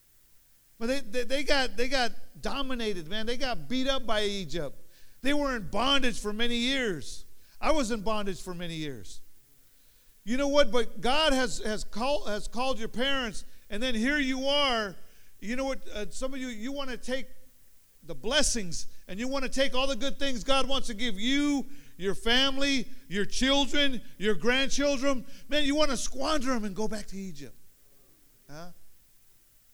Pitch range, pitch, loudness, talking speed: 205-270 Hz, 245 Hz, -29 LUFS, 185 wpm